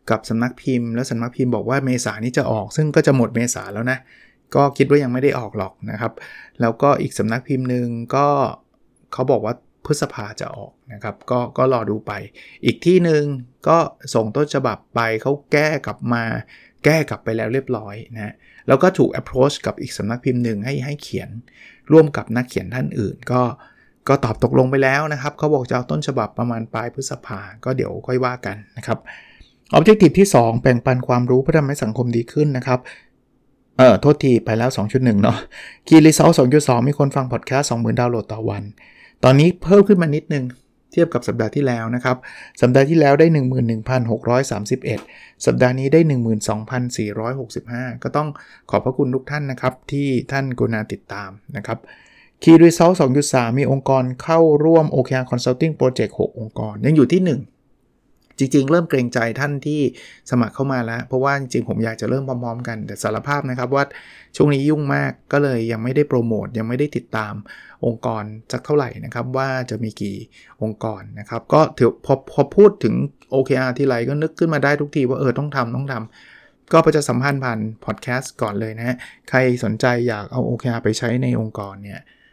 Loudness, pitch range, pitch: -18 LUFS, 115-140 Hz, 125 Hz